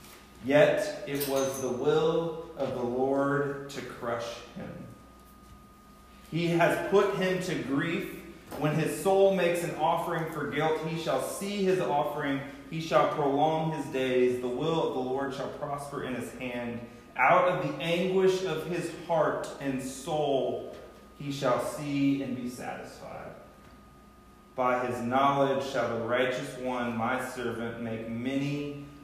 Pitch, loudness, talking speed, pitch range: 140 Hz, -29 LUFS, 145 wpm, 125-165 Hz